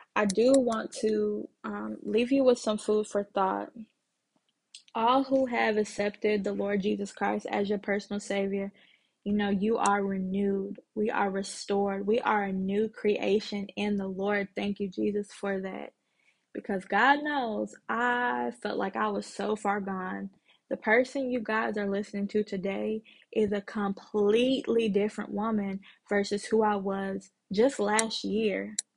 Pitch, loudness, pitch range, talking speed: 205 Hz, -29 LUFS, 200-220 Hz, 155 wpm